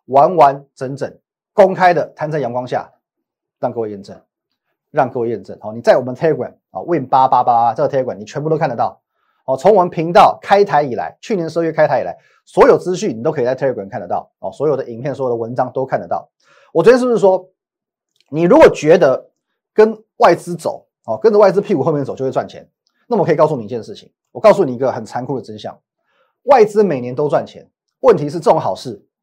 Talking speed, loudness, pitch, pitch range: 375 characters per minute, -15 LUFS, 160 Hz, 130-200 Hz